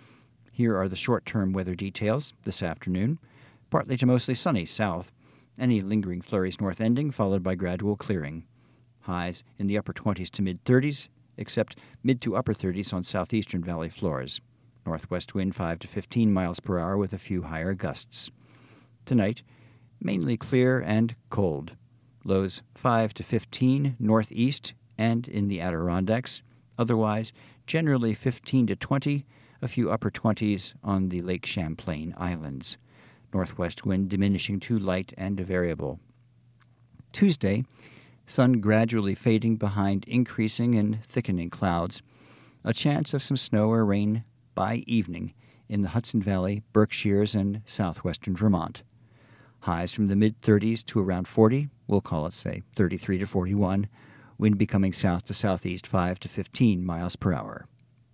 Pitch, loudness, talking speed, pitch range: 110 Hz, -27 LUFS, 150 wpm, 95-120 Hz